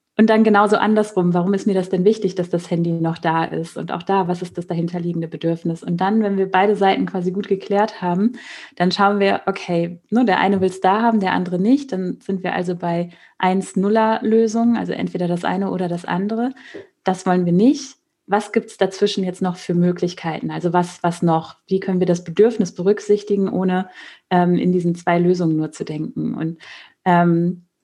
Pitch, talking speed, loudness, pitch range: 185 Hz, 205 wpm, -19 LUFS, 175-205 Hz